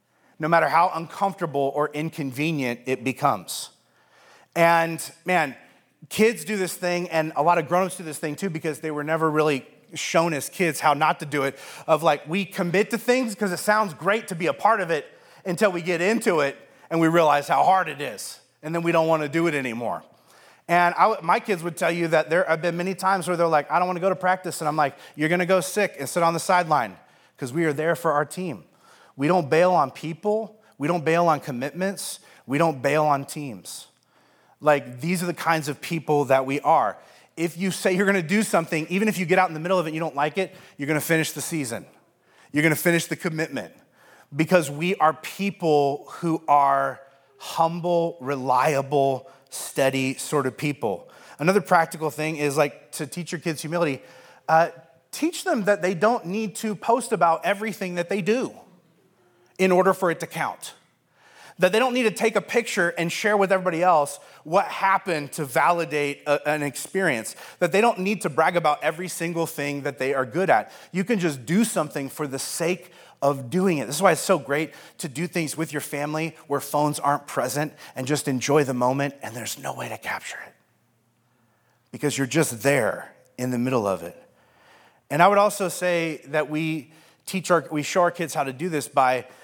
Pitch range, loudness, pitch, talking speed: 145-185 Hz, -23 LUFS, 165 Hz, 210 wpm